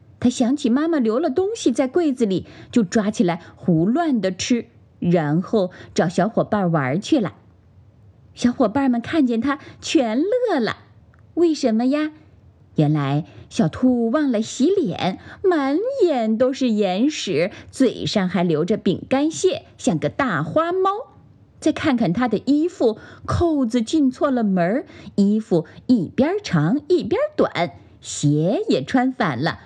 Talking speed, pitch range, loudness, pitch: 200 characters per minute, 180-300 Hz, -20 LUFS, 245 Hz